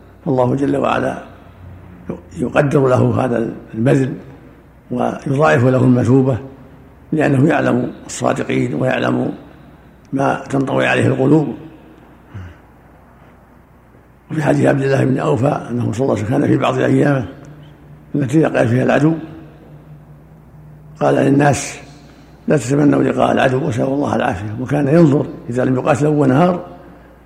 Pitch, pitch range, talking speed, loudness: 135 Hz, 125-150 Hz, 115 wpm, -16 LUFS